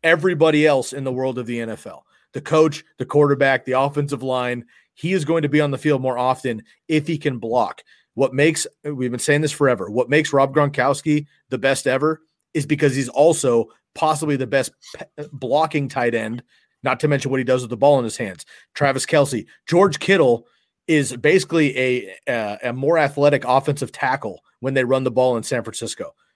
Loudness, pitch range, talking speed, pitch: -20 LUFS, 130-150 Hz, 200 wpm, 140 Hz